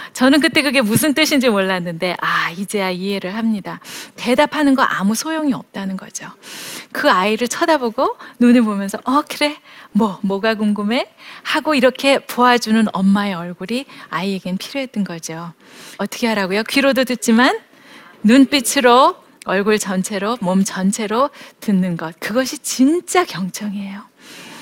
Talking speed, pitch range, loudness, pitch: 305 characters per minute, 195-275 Hz, -17 LUFS, 225 Hz